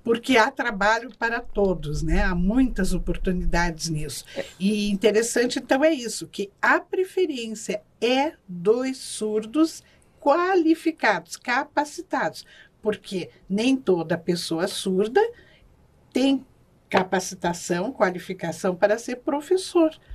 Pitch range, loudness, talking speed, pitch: 185-275 Hz, -24 LUFS, 100 wpm, 215 Hz